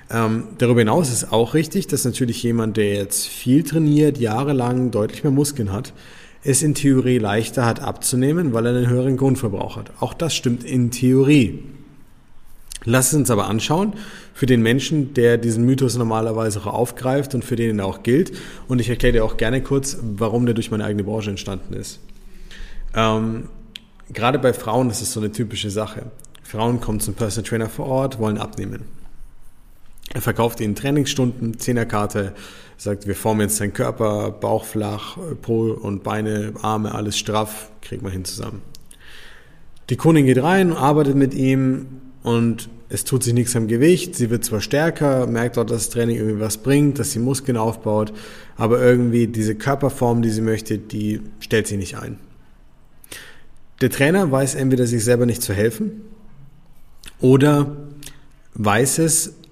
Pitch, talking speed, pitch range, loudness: 120 Hz, 170 wpm, 110-135 Hz, -19 LUFS